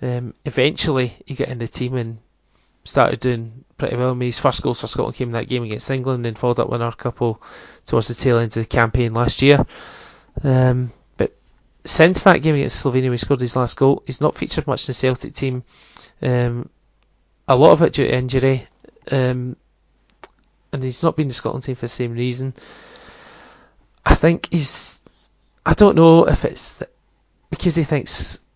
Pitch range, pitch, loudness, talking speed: 120-135 Hz, 125 Hz, -18 LUFS, 195 wpm